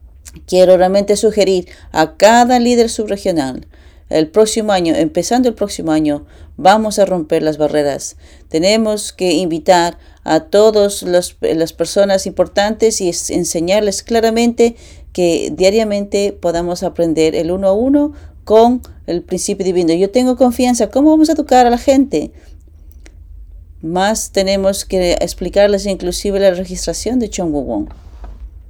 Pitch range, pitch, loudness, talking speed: 160-215 Hz, 190 Hz, -14 LUFS, 130 wpm